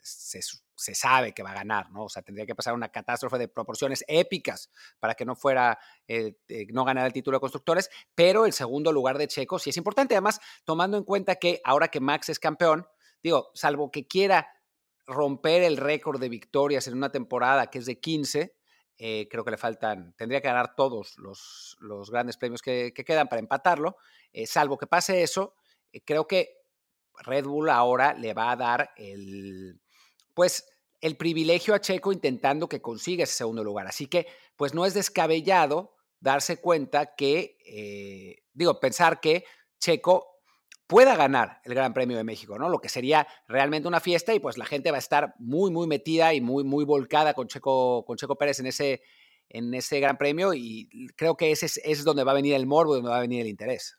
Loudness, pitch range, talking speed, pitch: -26 LUFS, 125-165 Hz, 200 wpm, 145 Hz